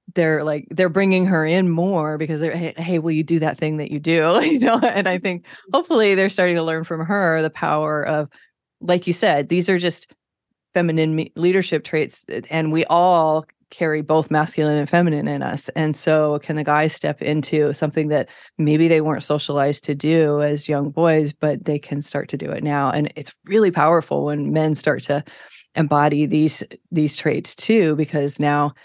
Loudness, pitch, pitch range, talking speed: -19 LUFS, 155 Hz, 150-170 Hz, 195 wpm